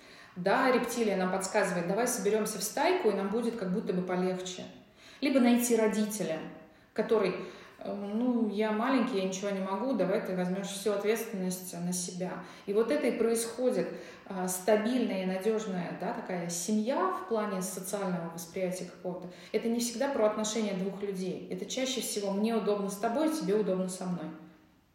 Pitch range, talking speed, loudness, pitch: 185-225 Hz, 160 wpm, -31 LUFS, 200 Hz